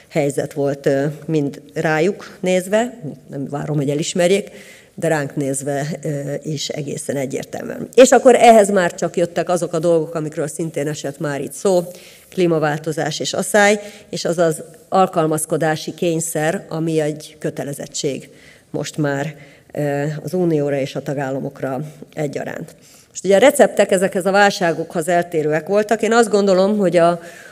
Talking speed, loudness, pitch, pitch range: 135 wpm, -18 LUFS, 165 Hz, 145-185 Hz